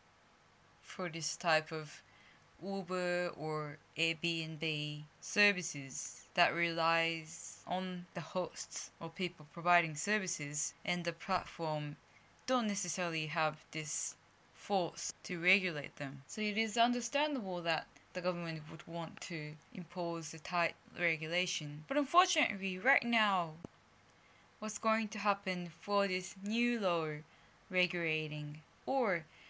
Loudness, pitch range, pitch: -36 LUFS, 160-190 Hz, 175 Hz